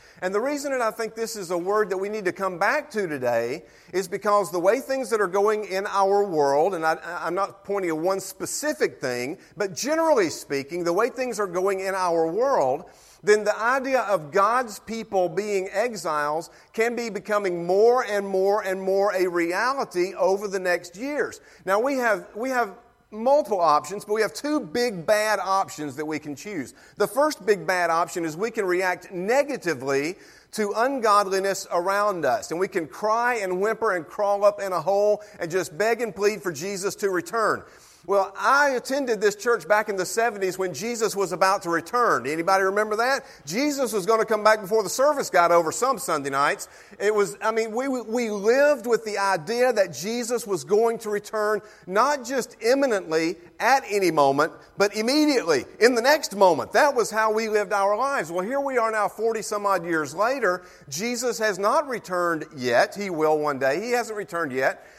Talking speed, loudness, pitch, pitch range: 195 wpm, -24 LUFS, 205 Hz, 185-230 Hz